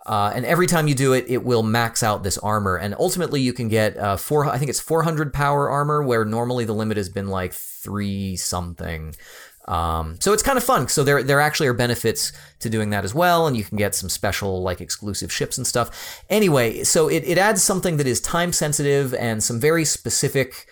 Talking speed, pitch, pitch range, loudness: 225 wpm, 120 Hz, 100-145 Hz, -21 LUFS